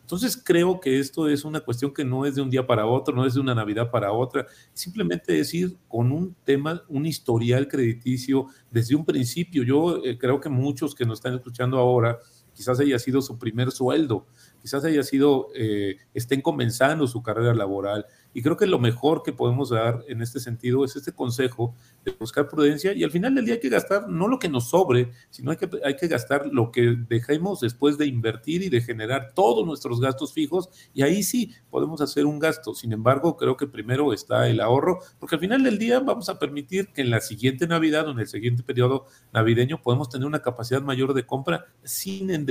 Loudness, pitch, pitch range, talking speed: -24 LUFS, 135 Hz, 120-155 Hz, 215 wpm